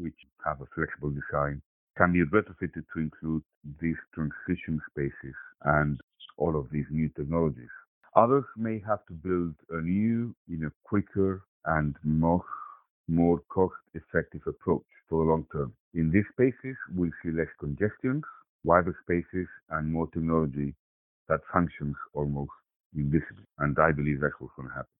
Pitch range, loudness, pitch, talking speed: 75-90 Hz, -30 LUFS, 80 Hz, 145 wpm